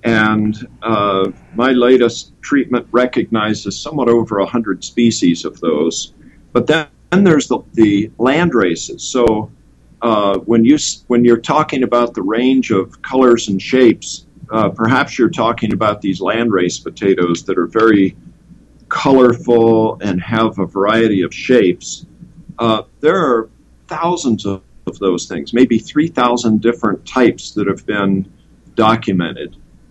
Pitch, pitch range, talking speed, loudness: 115 Hz, 100-125 Hz, 140 wpm, -14 LUFS